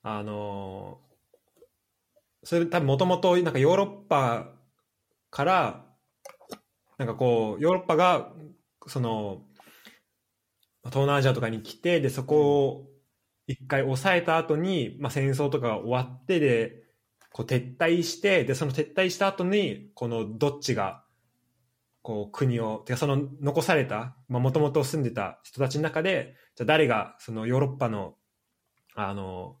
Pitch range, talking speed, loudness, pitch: 115-155 Hz, 260 characters per minute, -26 LUFS, 135 Hz